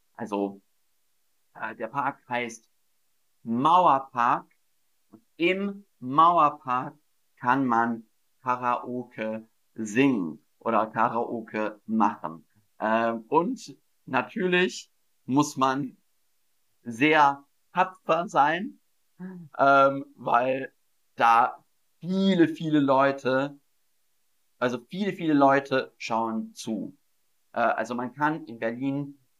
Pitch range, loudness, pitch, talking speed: 115-150 Hz, -25 LUFS, 130 Hz, 85 wpm